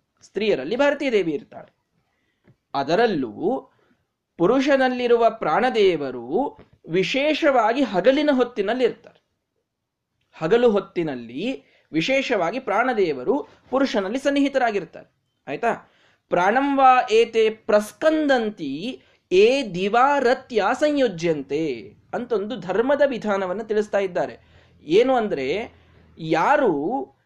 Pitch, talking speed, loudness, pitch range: 255 Hz, 70 wpm, -21 LUFS, 210-280 Hz